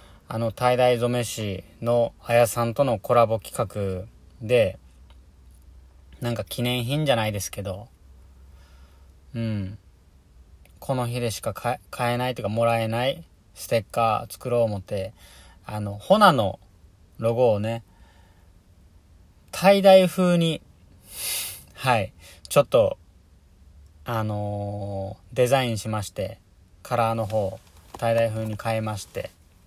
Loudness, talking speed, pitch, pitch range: -24 LUFS, 225 characters per minute, 100 Hz, 85-115 Hz